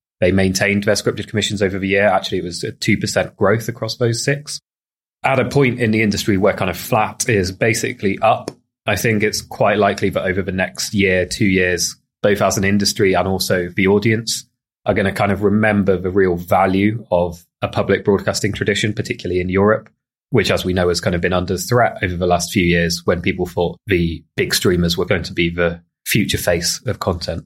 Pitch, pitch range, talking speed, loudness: 100 Hz, 90-105 Hz, 210 wpm, -17 LUFS